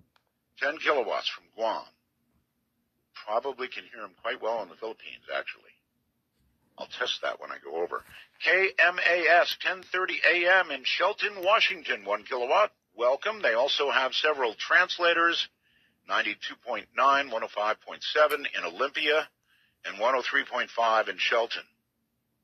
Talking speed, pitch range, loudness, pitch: 110 wpm, 130-170 Hz, -26 LUFS, 150 Hz